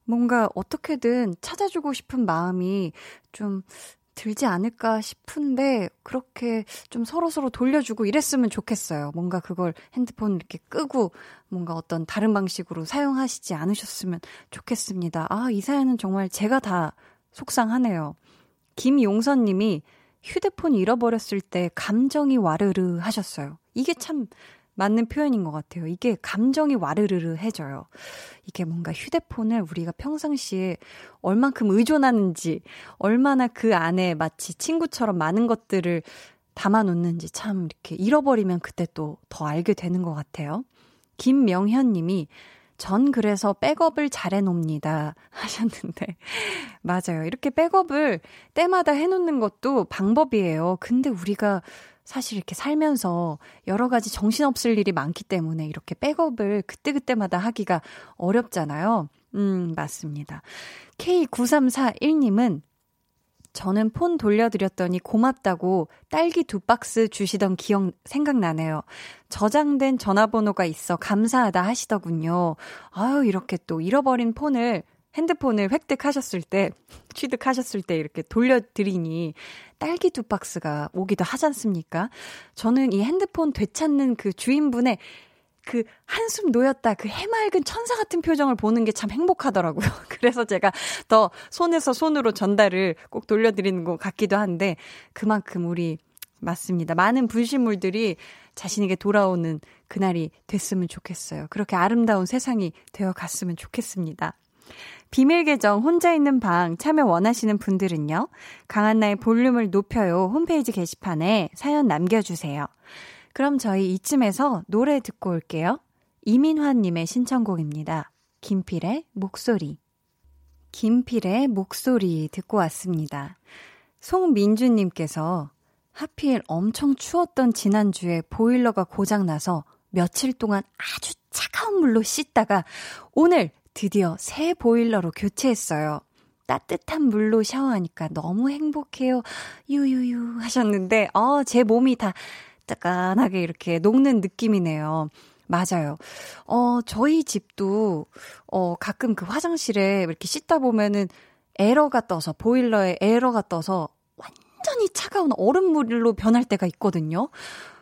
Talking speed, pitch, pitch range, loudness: 295 characters per minute, 215 Hz, 180-255 Hz, -23 LUFS